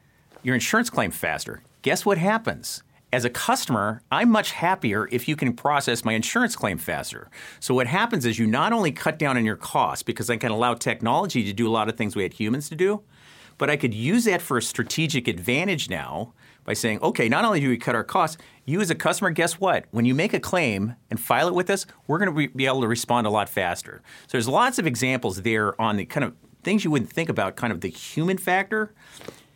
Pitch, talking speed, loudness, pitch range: 125 Hz, 235 wpm, -24 LUFS, 115-160 Hz